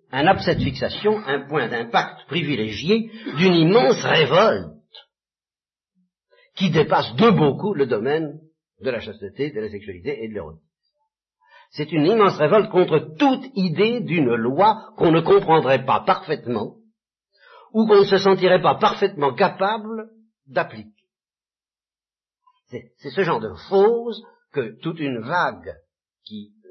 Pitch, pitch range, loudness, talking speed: 190 Hz, 150-220 Hz, -20 LUFS, 135 wpm